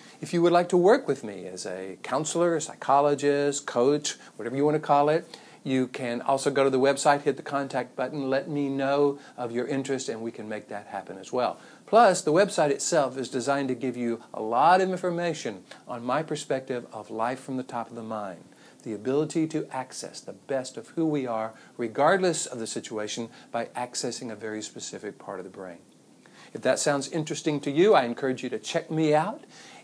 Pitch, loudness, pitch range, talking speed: 135 Hz, -27 LUFS, 120-150 Hz, 210 wpm